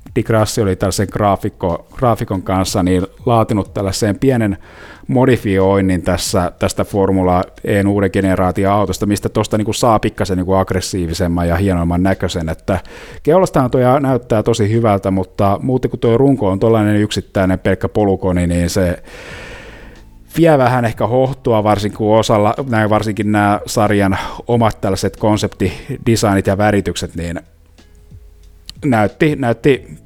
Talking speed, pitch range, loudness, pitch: 130 wpm, 95-115 Hz, -15 LUFS, 100 Hz